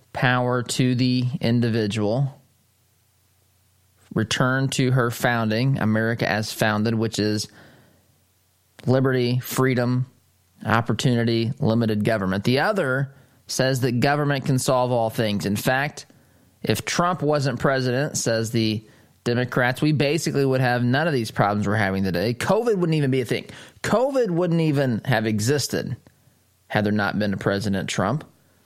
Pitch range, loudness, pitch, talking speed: 110-135 Hz, -22 LUFS, 120 Hz, 135 wpm